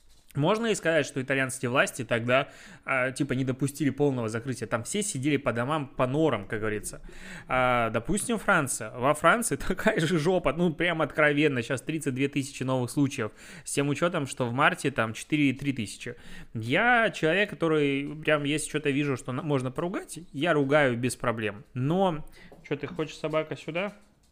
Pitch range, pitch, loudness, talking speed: 130-160 Hz, 145 Hz, -27 LUFS, 165 wpm